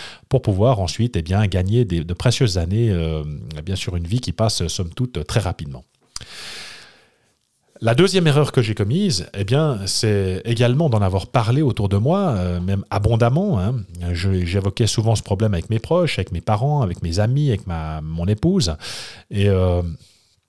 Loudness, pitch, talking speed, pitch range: -20 LUFS, 105 Hz, 180 wpm, 90-125 Hz